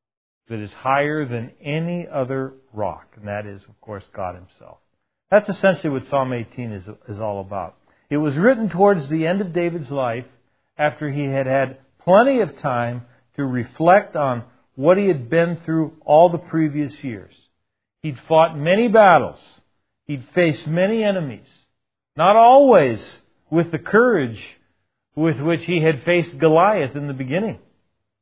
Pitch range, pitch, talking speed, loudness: 120-170 Hz, 145 Hz, 155 wpm, -18 LUFS